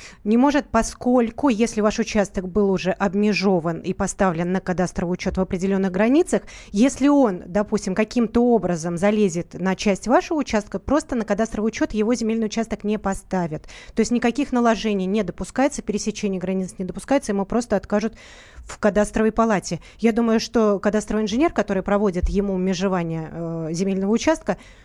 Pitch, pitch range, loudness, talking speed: 210 Hz, 190-230 Hz, -22 LUFS, 155 wpm